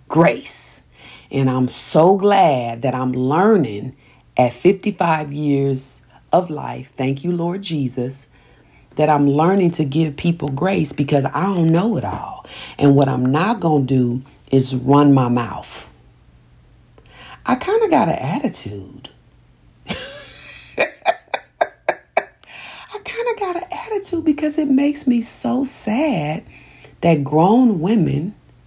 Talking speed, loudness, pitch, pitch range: 130 wpm, -18 LUFS, 155 Hz, 135-210 Hz